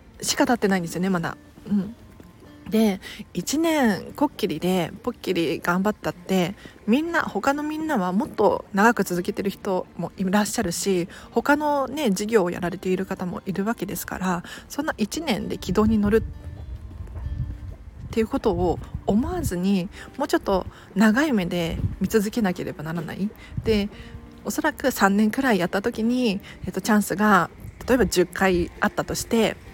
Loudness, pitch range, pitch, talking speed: -24 LUFS, 185-235 Hz, 205 Hz, 315 characters per minute